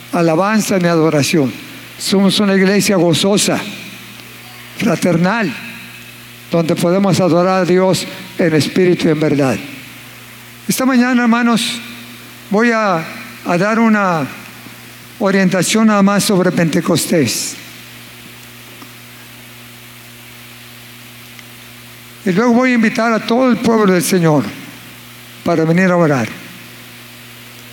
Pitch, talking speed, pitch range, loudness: 170 Hz, 100 wpm, 120-195 Hz, -14 LUFS